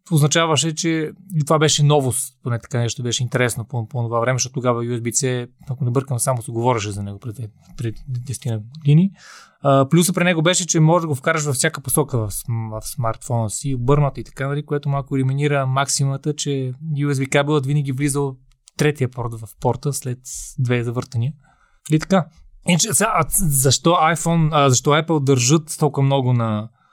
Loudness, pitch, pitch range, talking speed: -19 LUFS, 140 Hz, 125-150 Hz, 170 wpm